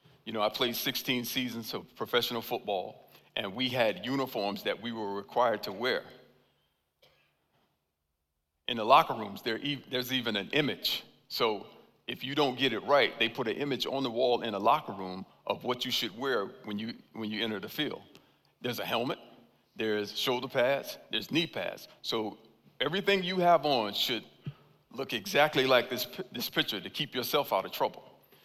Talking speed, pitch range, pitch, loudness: 175 wpm, 100-130 Hz, 115 Hz, -31 LUFS